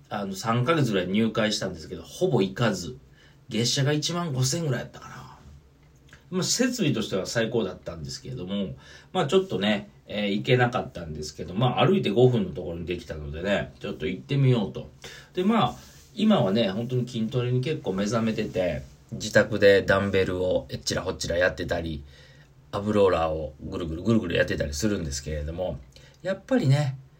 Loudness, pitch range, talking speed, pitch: -26 LUFS, 90-135 Hz, 385 characters per minute, 110 Hz